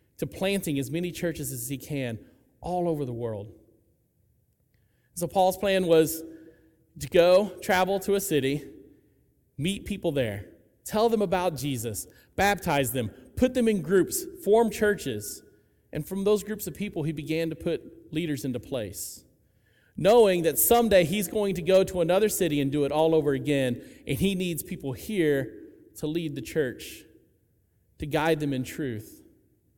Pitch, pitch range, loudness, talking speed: 160 Hz, 135-190 Hz, -26 LUFS, 160 wpm